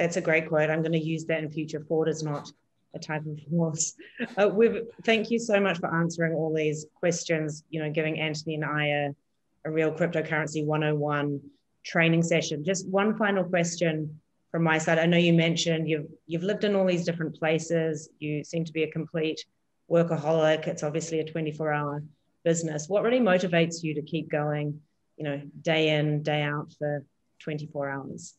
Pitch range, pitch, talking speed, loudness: 150-170 Hz, 160 Hz, 185 wpm, -27 LUFS